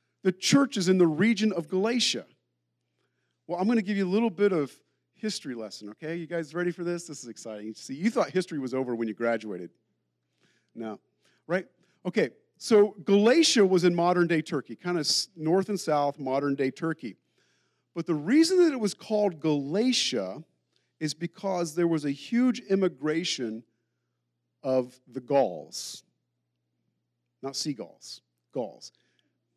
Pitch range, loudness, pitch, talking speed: 115-195 Hz, -27 LUFS, 160 Hz, 155 wpm